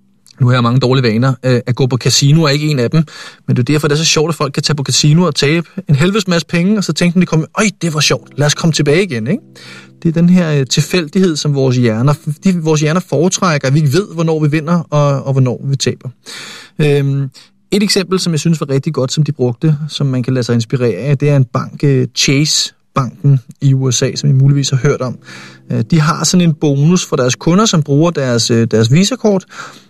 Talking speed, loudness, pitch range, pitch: 235 wpm, -13 LUFS, 130-165 Hz, 145 Hz